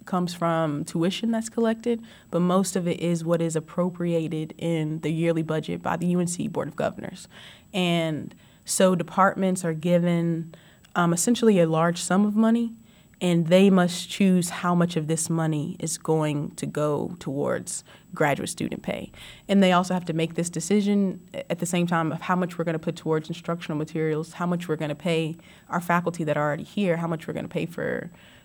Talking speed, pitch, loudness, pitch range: 195 wpm, 170 Hz, -25 LUFS, 165-185 Hz